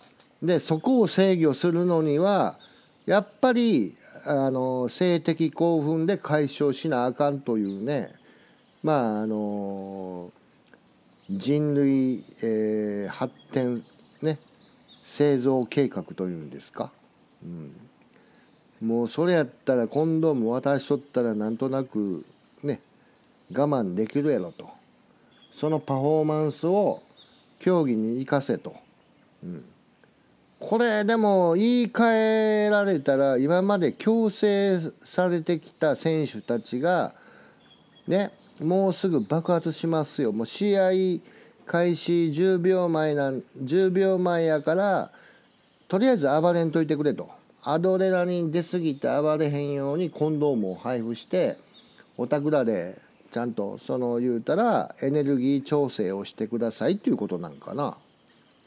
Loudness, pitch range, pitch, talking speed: -25 LUFS, 130-185 Hz, 155 Hz, 245 characters per minute